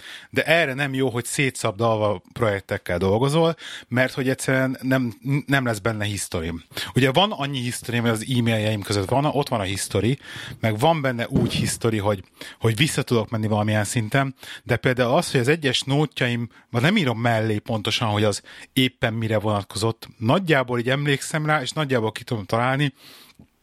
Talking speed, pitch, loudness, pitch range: 170 wpm, 120 Hz, -22 LUFS, 110-135 Hz